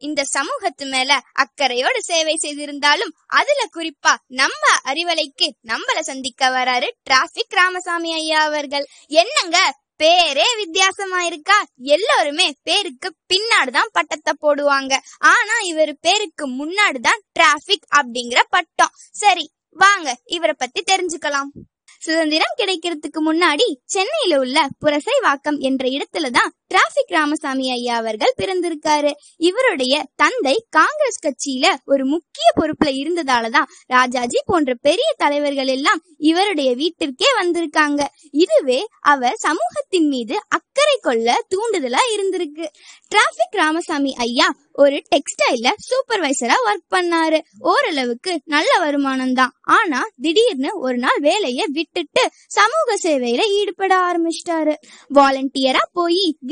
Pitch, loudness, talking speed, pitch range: 315 Hz, -17 LUFS, 100 wpm, 280-360 Hz